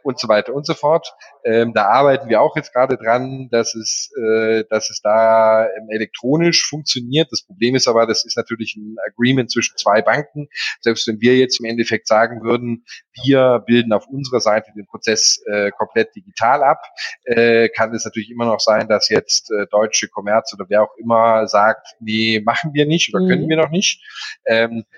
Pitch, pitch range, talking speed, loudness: 115 Hz, 110-130 Hz, 195 wpm, -16 LUFS